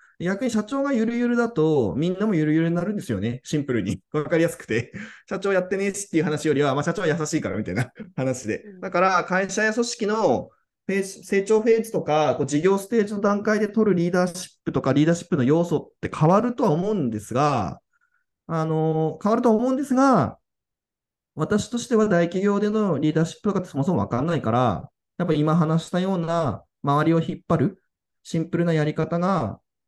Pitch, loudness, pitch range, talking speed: 175 Hz, -23 LUFS, 155-210 Hz, 420 characters per minute